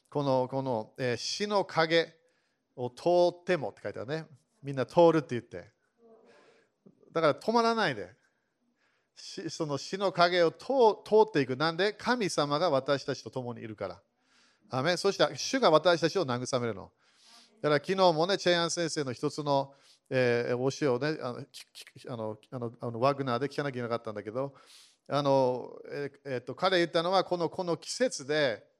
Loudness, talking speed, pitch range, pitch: -29 LUFS, 325 characters per minute, 130-180 Hz, 150 Hz